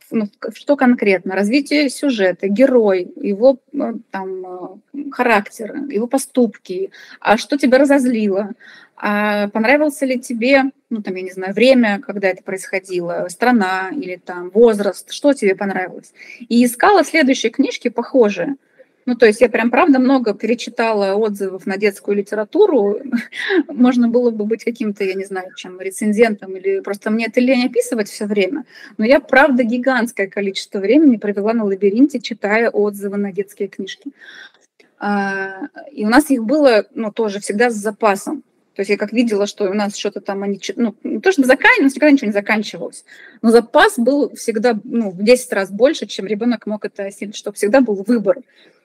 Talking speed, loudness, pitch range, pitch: 165 wpm, -16 LUFS, 200-265 Hz, 225 Hz